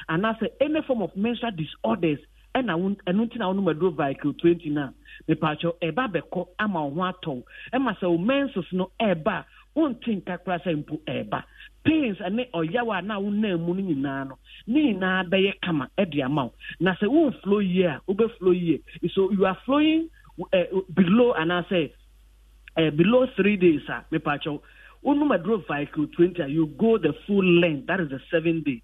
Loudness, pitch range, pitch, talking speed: -25 LUFS, 160-220 Hz, 185 Hz, 200 wpm